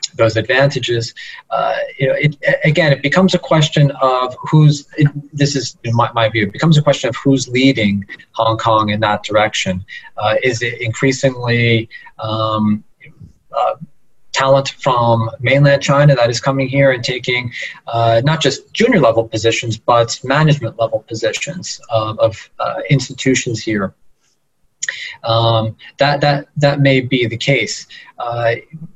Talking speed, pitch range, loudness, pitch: 150 wpm, 115-140 Hz, -15 LUFS, 130 Hz